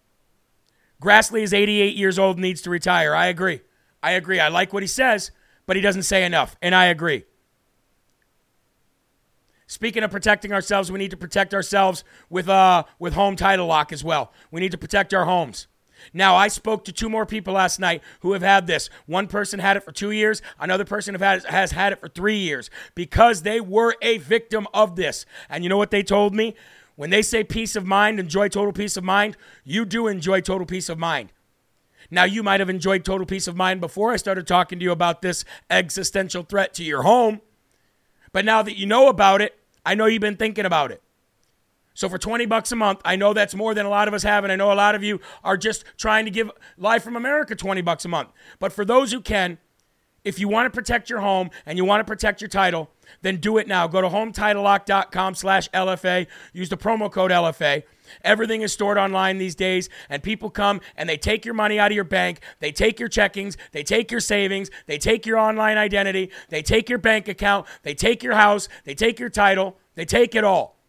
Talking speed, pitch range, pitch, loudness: 225 wpm, 185-215 Hz, 195 Hz, -20 LUFS